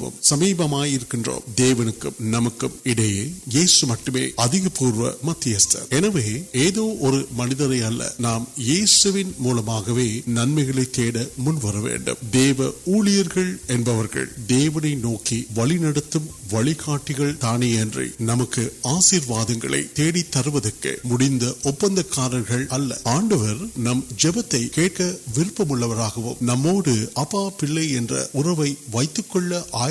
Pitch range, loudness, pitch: 120-160 Hz, -21 LUFS, 130 Hz